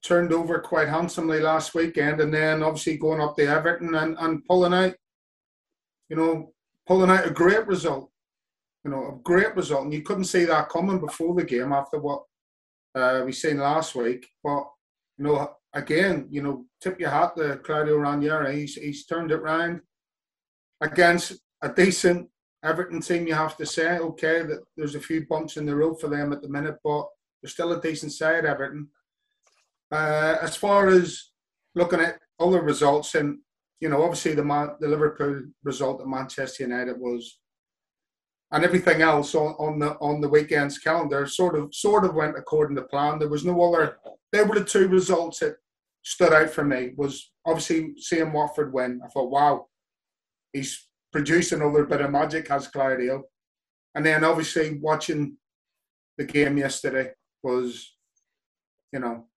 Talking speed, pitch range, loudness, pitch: 175 wpm, 145-165 Hz, -24 LUFS, 155 Hz